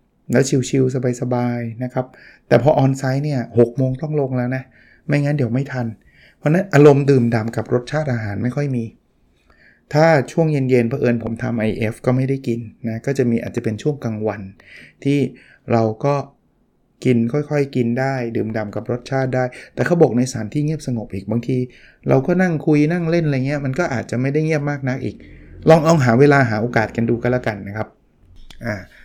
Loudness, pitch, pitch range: -19 LUFS, 125 Hz, 115-140 Hz